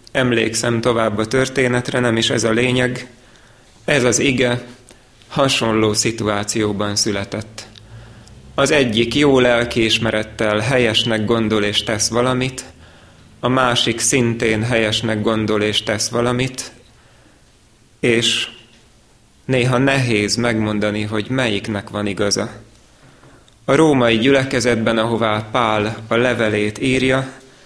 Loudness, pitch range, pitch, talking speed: -17 LUFS, 110-125 Hz, 115 Hz, 105 wpm